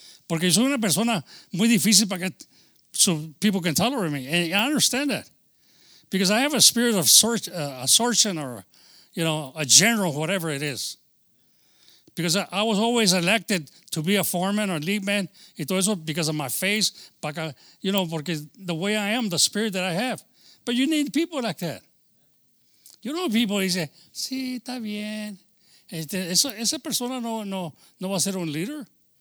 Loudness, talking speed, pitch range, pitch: -22 LUFS, 180 wpm, 170-225 Hz, 195 Hz